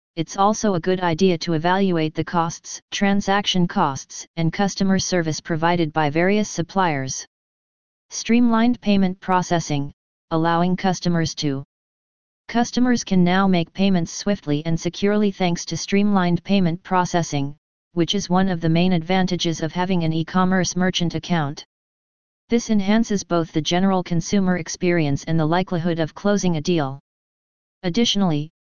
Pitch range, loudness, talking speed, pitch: 165-195 Hz, -21 LUFS, 140 wpm, 180 Hz